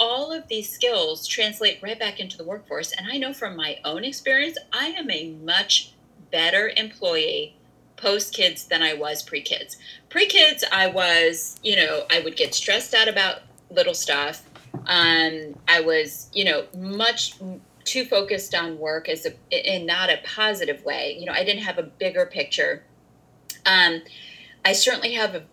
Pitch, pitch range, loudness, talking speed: 210 Hz, 170-275 Hz, -21 LUFS, 165 wpm